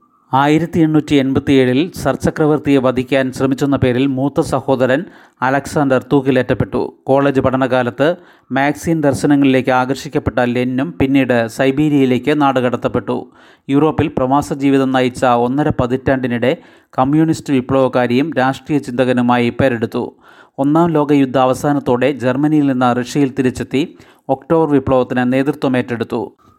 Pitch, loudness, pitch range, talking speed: 135 Hz, -15 LUFS, 125-145 Hz, 95 wpm